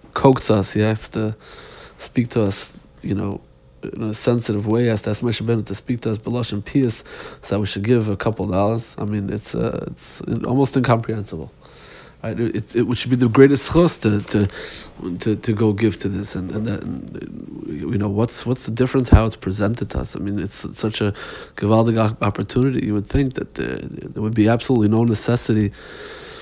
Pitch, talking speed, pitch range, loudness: 110 Hz, 205 wpm, 105-120 Hz, -20 LUFS